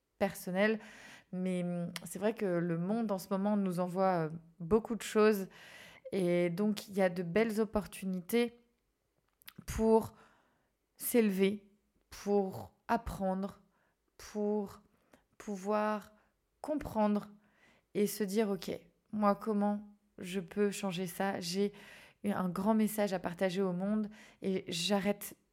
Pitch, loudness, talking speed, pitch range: 205 Hz, -34 LUFS, 120 wpm, 190-215 Hz